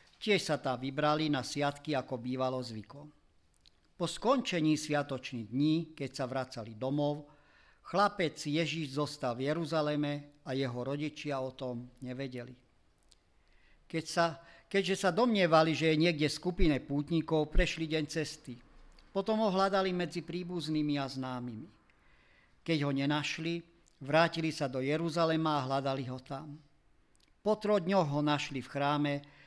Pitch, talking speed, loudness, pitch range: 150 Hz, 135 wpm, -33 LUFS, 130-165 Hz